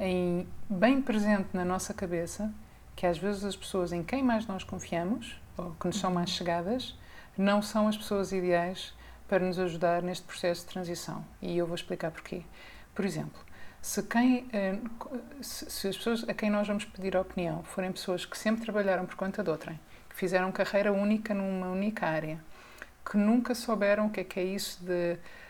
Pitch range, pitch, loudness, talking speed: 180-210 Hz, 190 Hz, -32 LUFS, 185 wpm